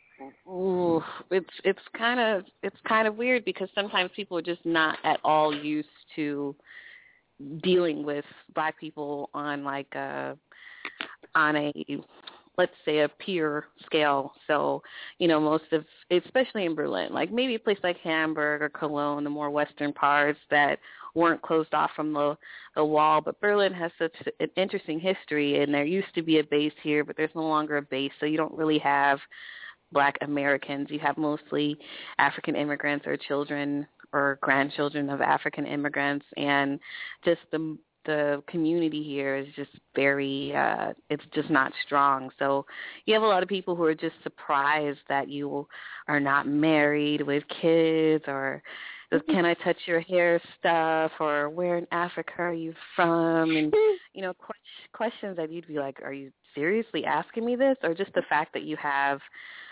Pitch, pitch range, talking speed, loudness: 155 Hz, 145-170 Hz, 170 wpm, -27 LUFS